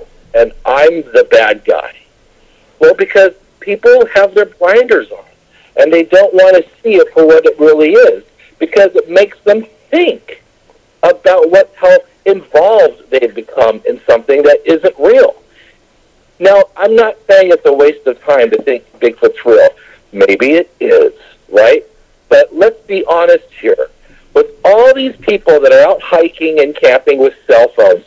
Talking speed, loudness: 160 wpm, -8 LUFS